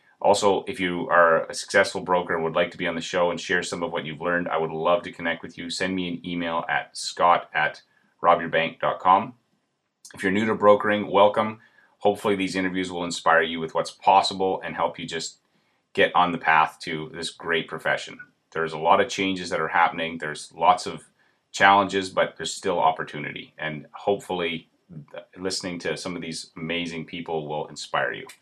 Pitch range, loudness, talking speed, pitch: 80-95 Hz, -24 LUFS, 195 wpm, 85 Hz